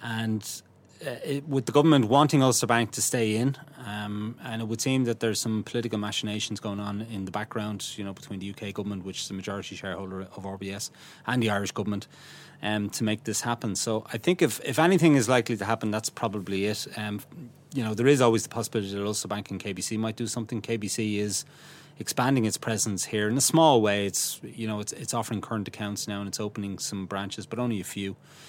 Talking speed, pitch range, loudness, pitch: 220 wpm, 100-120 Hz, -27 LUFS, 110 Hz